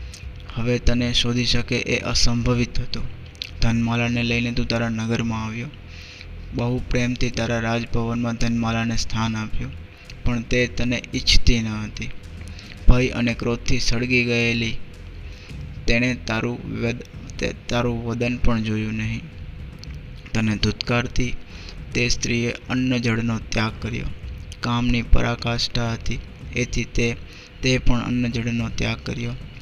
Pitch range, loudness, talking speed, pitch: 100-120 Hz, -23 LUFS, 115 wpm, 115 Hz